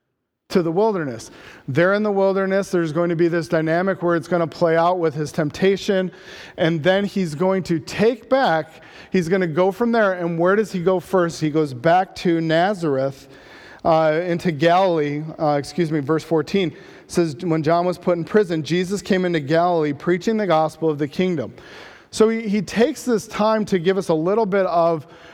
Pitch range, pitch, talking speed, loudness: 160-195 Hz, 175 Hz, 200 wpm, -20 LUFS